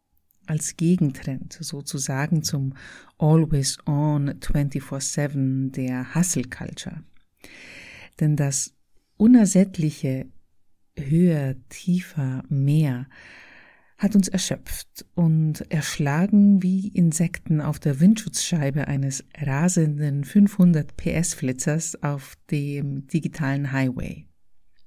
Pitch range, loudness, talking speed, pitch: 140-170 Hz, -23 LUFS, 70 wpm, 150 Hz